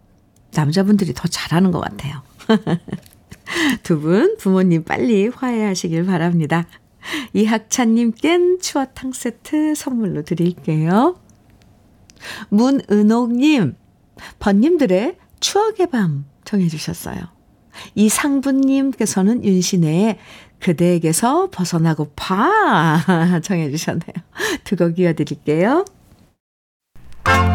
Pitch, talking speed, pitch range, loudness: 195 Hz, 215 characters per minute, 170-250 Hz, -17 LUFS